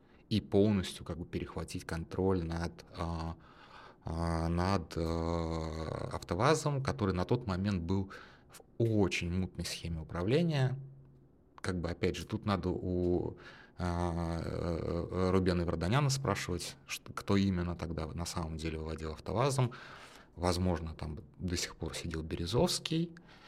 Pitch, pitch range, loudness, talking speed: 90 Hz, 85-100 Hz, -35 LUFS, 110 wpm